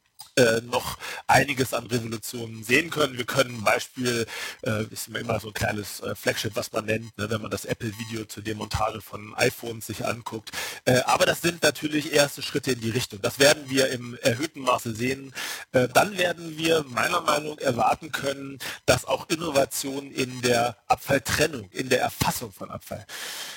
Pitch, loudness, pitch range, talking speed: 125 Hz, -25 LUFS, 110-140 Hz, 175 wpm